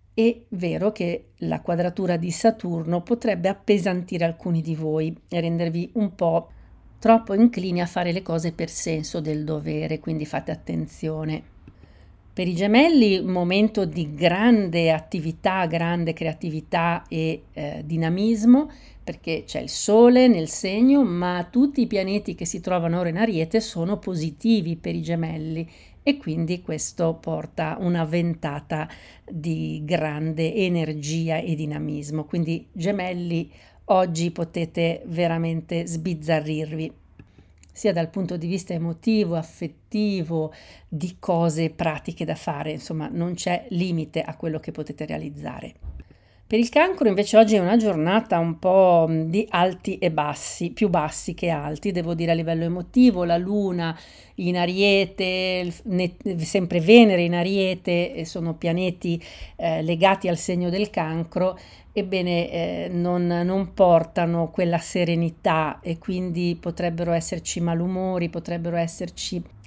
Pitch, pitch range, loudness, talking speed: 175 Hz, 165-190 Hz, -23 LUFS, 135 wpm